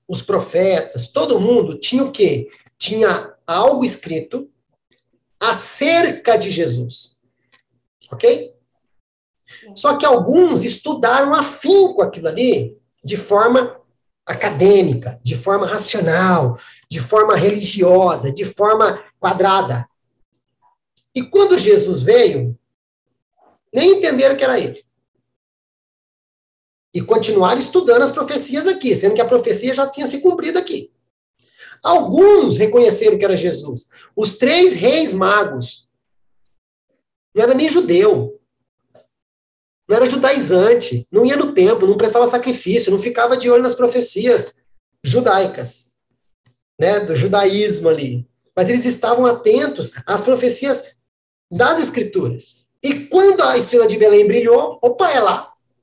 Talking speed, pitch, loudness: 120 wpm, 240 Hz, -14 LUFS